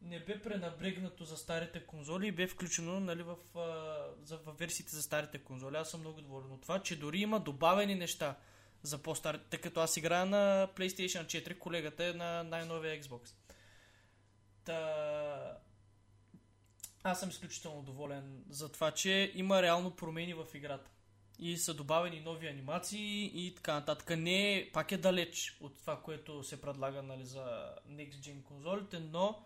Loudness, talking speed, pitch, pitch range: -38 LUFS, 160 wpm, 165 Hz, 145-175 Hz